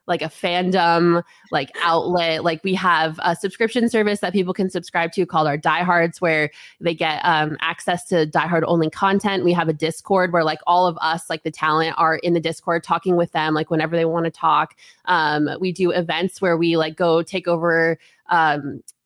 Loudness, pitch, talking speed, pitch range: -20 LUFS, 170 Hz, 200 wpm, 160-180 Hz